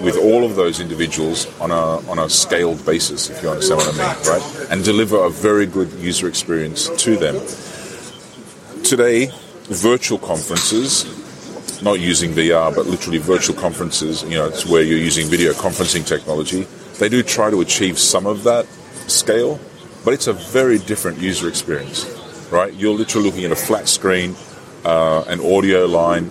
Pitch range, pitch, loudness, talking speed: 85-105 Hz, 90 Hz, -17 LUFS, 170 wpm